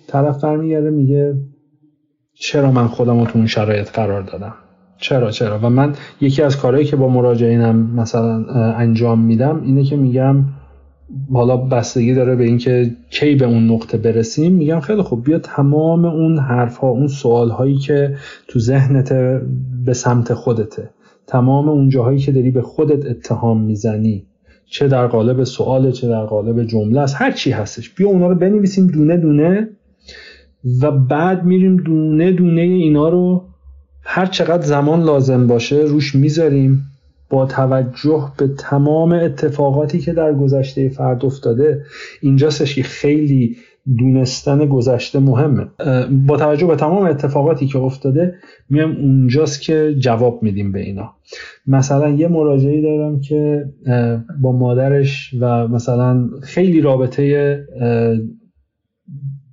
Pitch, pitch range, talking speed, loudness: 135 Hz, 120-150 Hz, 135 wpm, -15 LUFS